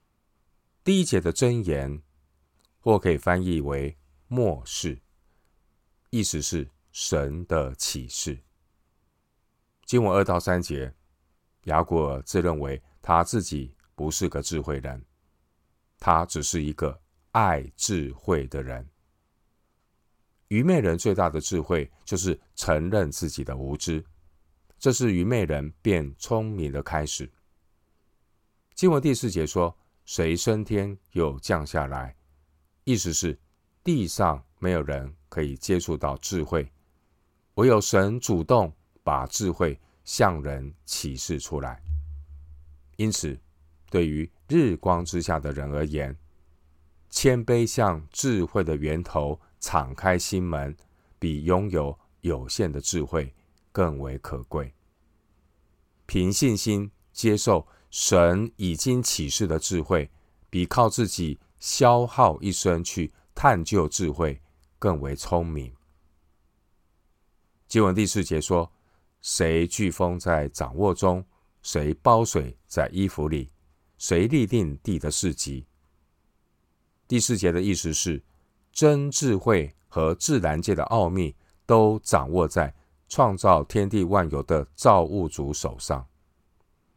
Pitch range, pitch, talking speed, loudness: 75-90 Hz, 80 Hz, 170 characters per minute, -25 LUFS